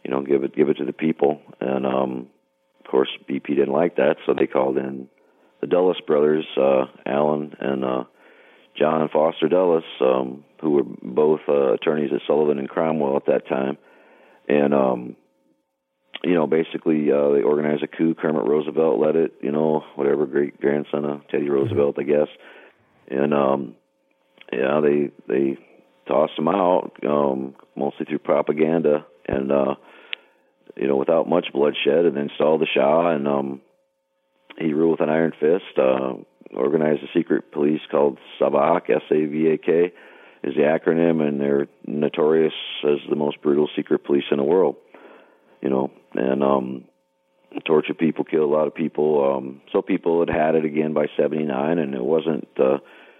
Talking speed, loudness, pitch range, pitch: 170 wpm, -21 LUFS, 65-75 Hz, 70 Hz